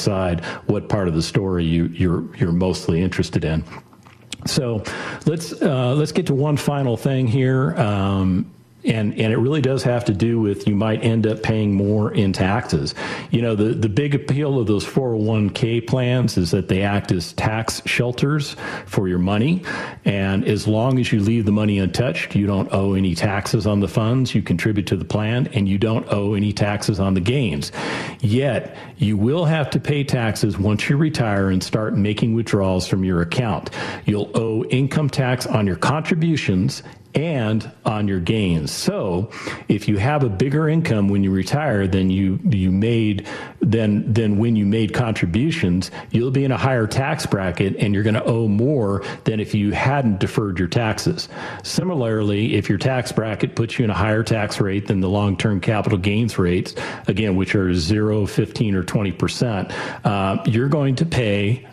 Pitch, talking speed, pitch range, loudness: 110 Hz, 185 wpm, 100-130 Hz, -20 LUFS